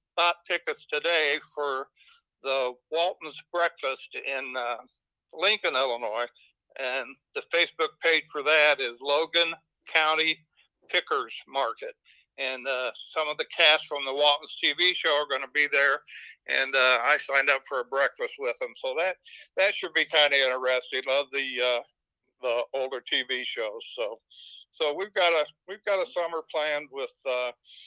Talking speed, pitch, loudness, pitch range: 160 wpm, 155 Hz, -26 LUFS, 140-195 Hz